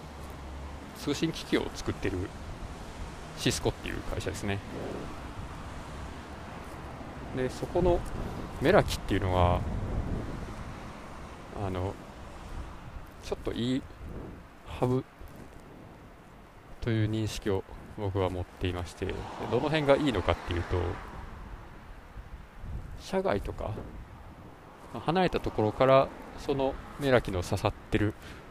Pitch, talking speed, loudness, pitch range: 95 Hz, 200 characters per minute, -31 LUFS, 85-110 Hz